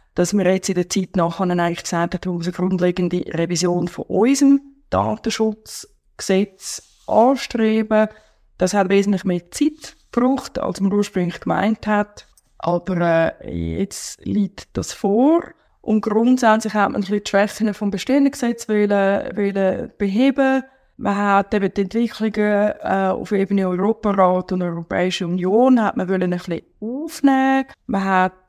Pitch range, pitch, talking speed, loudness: 185-225 Hz, 200 Hz, 135 wpm, -19 LUFS